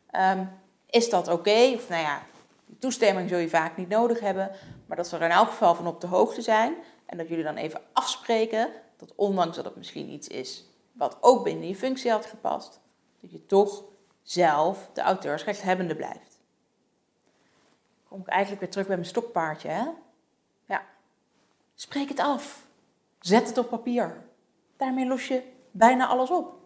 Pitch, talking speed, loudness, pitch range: 215 Hz, 175 wpm, -26 LUFS, 185-250 Hz